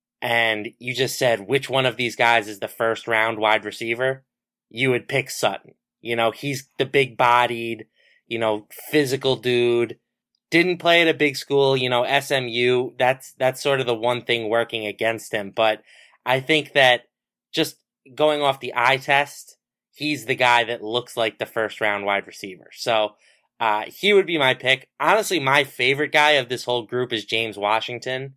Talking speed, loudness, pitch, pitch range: 185 wpm, -21 LUFS, 125 Hz, 115-135 Hz